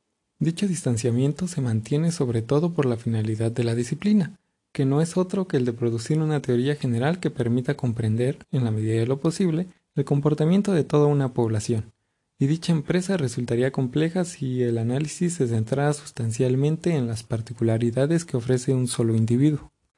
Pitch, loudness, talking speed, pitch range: 135 Hz, -24 LUFS, 170 wpm, 120-160 Hz